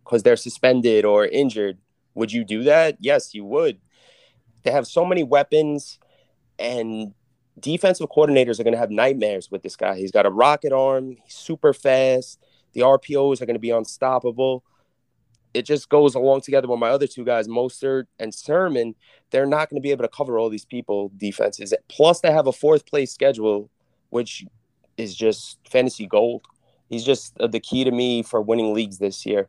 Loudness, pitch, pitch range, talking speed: -20 LUFS, 130 Hz, 115-145 Hz, 185 wpm